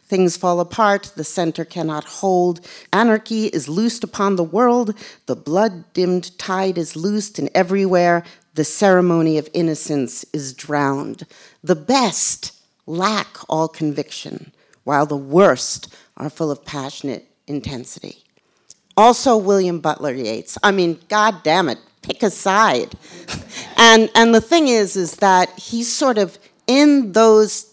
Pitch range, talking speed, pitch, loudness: 155-215 Hz, 140 wpm, 180 Hz, -17 LUFS